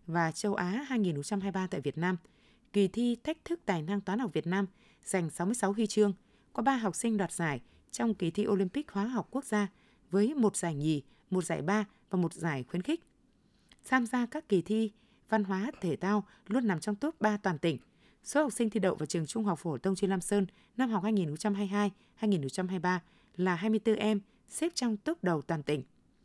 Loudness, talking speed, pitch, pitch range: -32 LUFS, 205 wpm, 205 Hz, 180-220 Hz